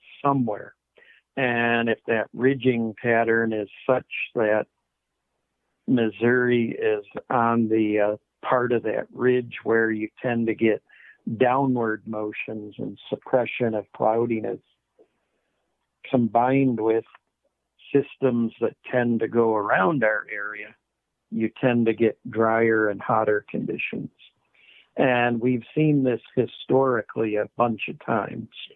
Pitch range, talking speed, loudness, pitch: 110-125 Hz, 115 wpm, -24 LUFS, 115 Hz